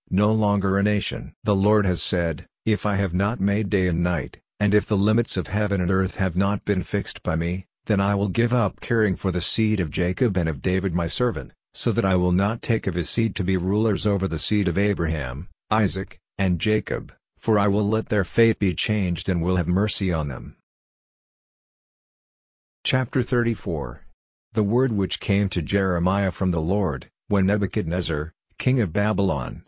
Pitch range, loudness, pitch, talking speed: 90-105 Hz, -23 LUFS, 100 Hz, 195 wpm